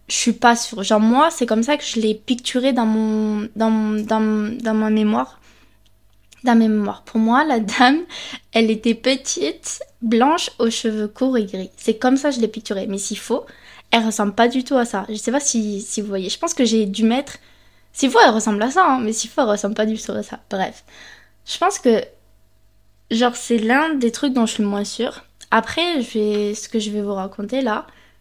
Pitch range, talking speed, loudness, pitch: 210-250 Hz, 230 wpm, -19 LUFS, 225 Hz